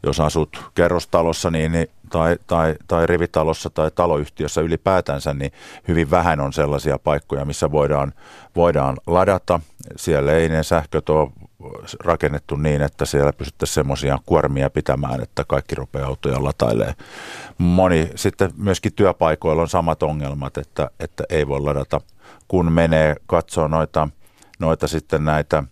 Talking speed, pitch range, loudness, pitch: 140 wpm, 70-85 Hz, -20 LUFS, 80 Hz